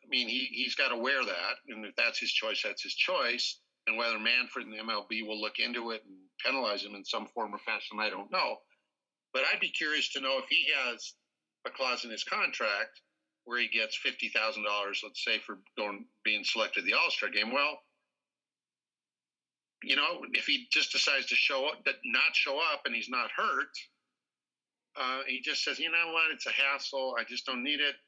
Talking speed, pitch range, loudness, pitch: 205 wpm, 110-140 Hz, -30 LUFS, 125 Hz